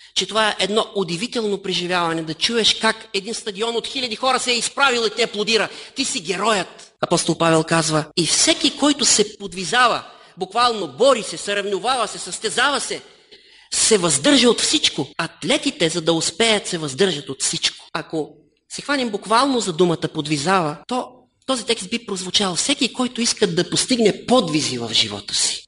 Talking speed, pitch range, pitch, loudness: 165 wpm, 175-240 Hz, 210 Hz, -19 LUFS